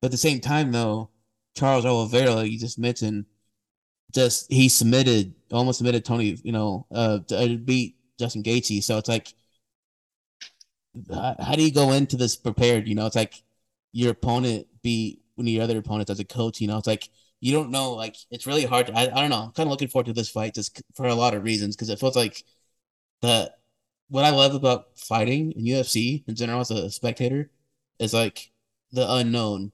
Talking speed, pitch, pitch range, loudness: 205 wpm, 120 Hz, 110-125 Hz, -24 LUFS